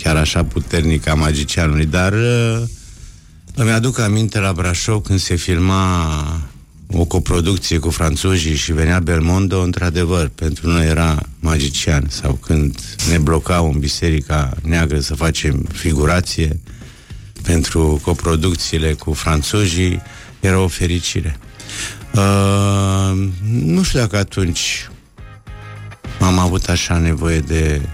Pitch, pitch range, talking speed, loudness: 85 Hz, 80-100 Hz, 115 wpm, -17 LUFS